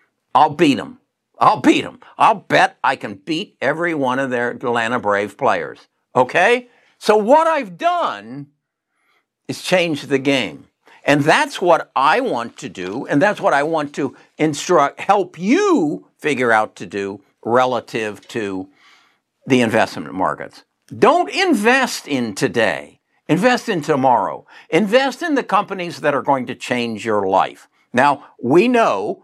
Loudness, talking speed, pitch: -17 LUFS, 150 wpm, 165 Hz